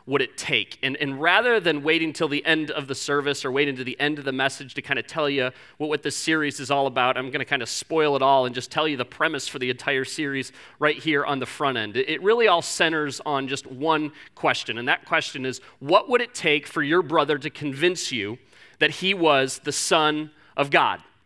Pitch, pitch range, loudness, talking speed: 145 Hz, 135-155 Hz, -23 LUFS, 245 wpm